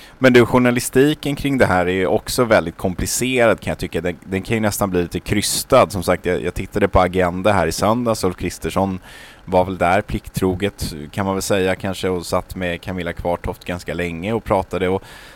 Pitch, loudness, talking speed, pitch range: 95 Hz, -19 LUFS, 205 wpm, 90-110 Hz